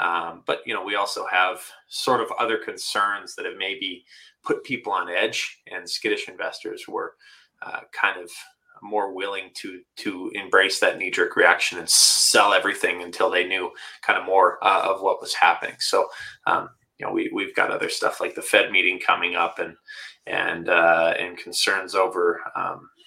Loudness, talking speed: -22 LUFS, 180 wpm